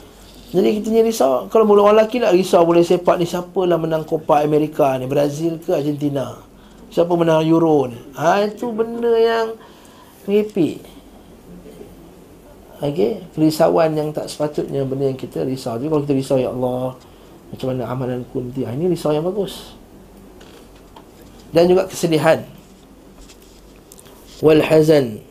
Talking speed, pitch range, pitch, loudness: 140 wpm, 140-190 Hz, 160 Hz, -18 LUFS